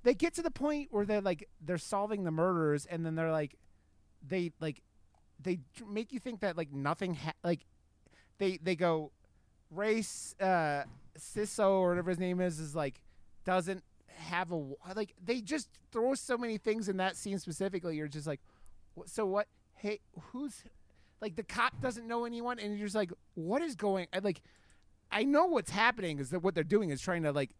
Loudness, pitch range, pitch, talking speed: -35 LUFS, 155-215 Hz, 185 Hz, 195 wpm